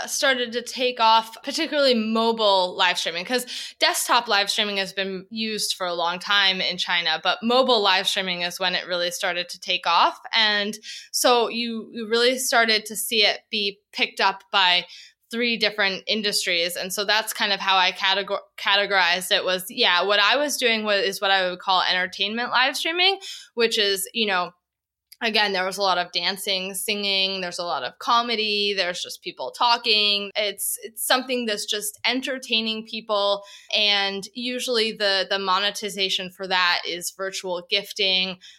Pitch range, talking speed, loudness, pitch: 190-235 Hz, 175 wpm, -21 LUFS, 205 Hz